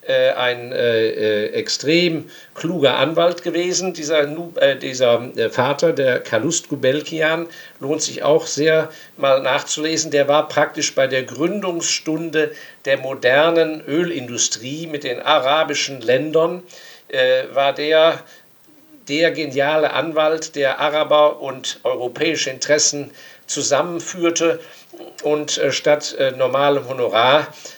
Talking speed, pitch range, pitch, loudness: 110 wpm, 150-175 Hz, 160 Hz, -18 LUFS